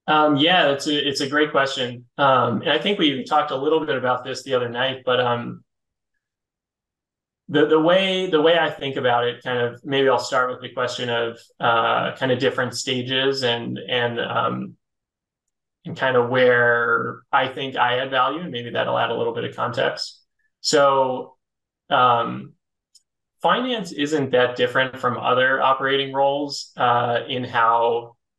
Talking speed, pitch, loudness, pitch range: 170 wpm, 130 Hz, -20 LUFS, 120-145 Hz